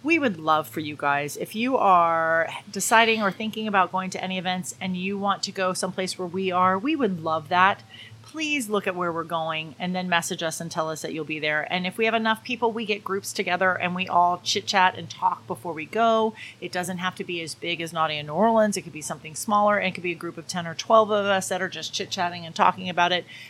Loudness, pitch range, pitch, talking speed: -24 LUFS, 165-200 Hz, 185 Hz, 270 wpm